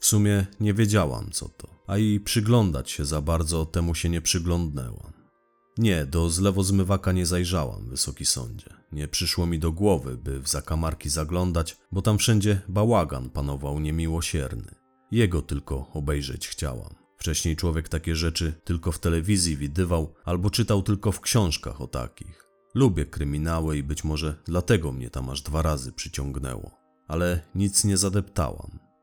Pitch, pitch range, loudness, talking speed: 85 Hz, 75-100 Hz, -26 LUFS, 155 wpm